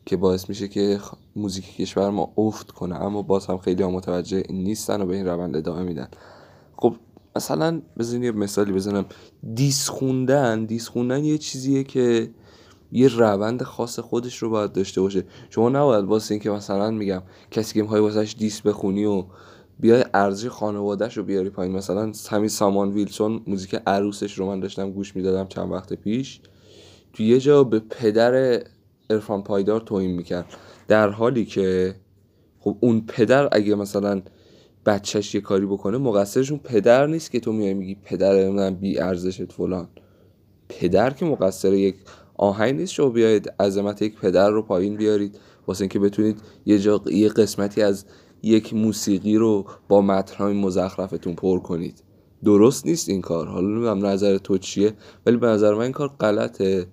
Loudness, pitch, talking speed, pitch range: -22 LUFS, 100 Hz, 165 wpm, 95-110 Hz